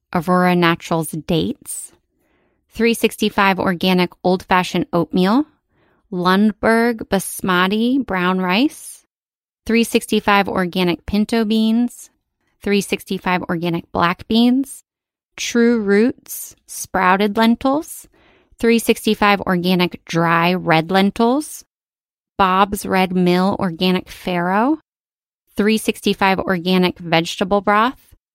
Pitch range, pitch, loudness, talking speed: 180-225 Hz, 195 Hz, -17 LUFS, 80 wpm